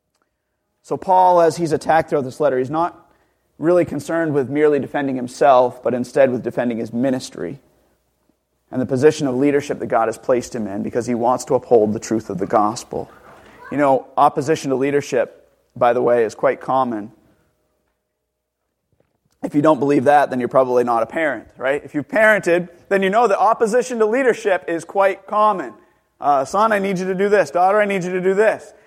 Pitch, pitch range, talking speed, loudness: 145 Hz, 125-185 Hz, 195 wpm, -18 LUFS